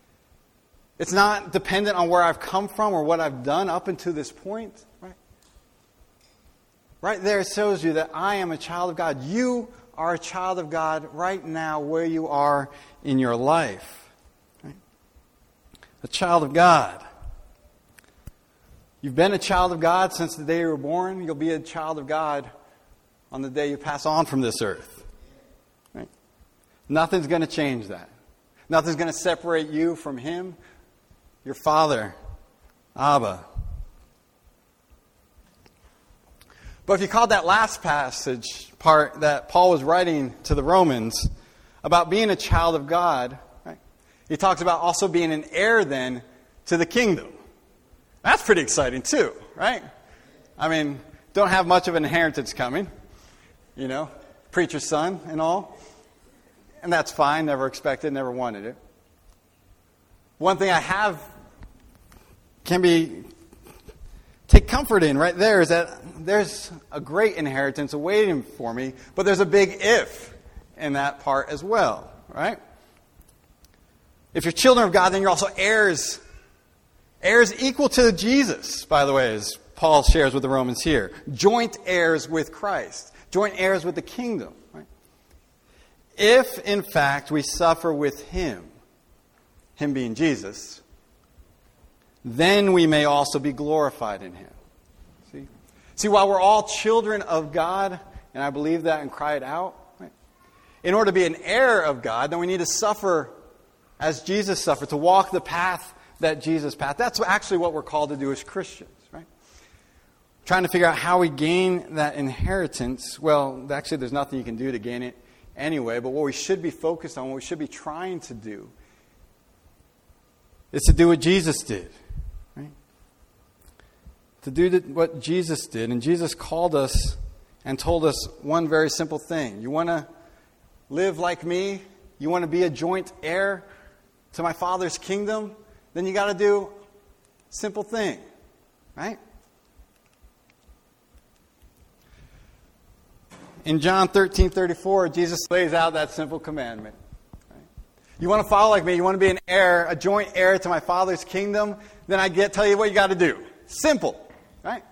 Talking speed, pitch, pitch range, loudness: 160 wpm, 165 Hz, 140-190 Hz, -22 LUFS